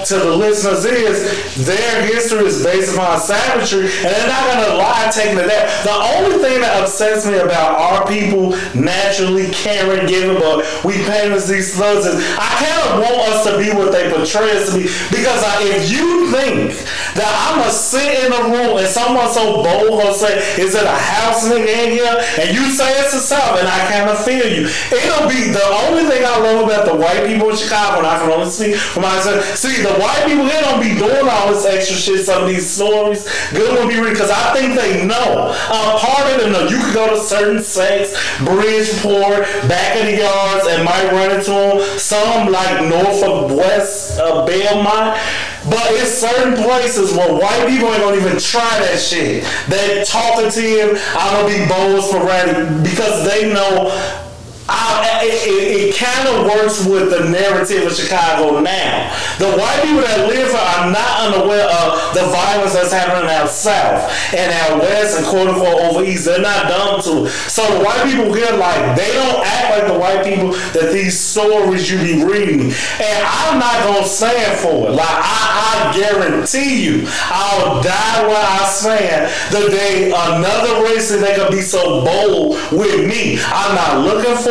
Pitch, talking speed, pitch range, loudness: 205 Hz, 195 wpm, 190-225 Hz, -13 LUFS